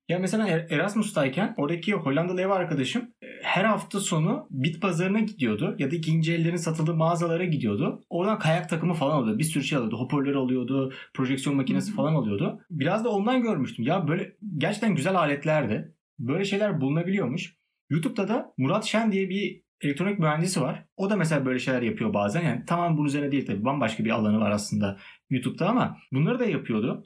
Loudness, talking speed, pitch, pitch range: -26 LUFS, 175 wpm, 170 Hz, 140-200 Hz